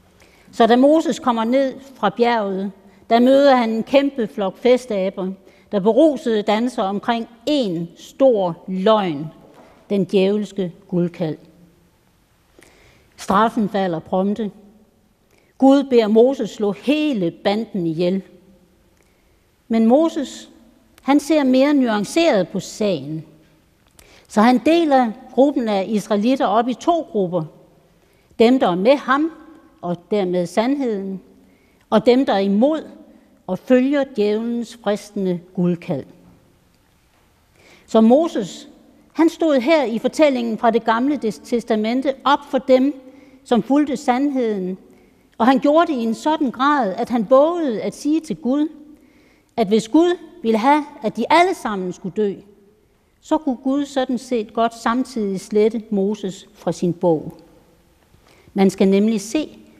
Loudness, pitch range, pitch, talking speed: -18 LUFS, 195-270 Hz, 225 Hz, 130 wpm